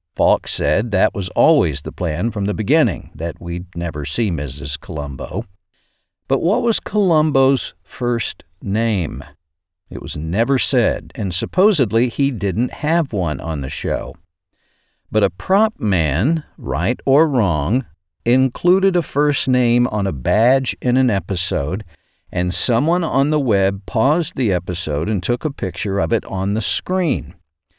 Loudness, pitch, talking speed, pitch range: -18 LUFS, 105 Hz, 150 wpm, 85-130 Hz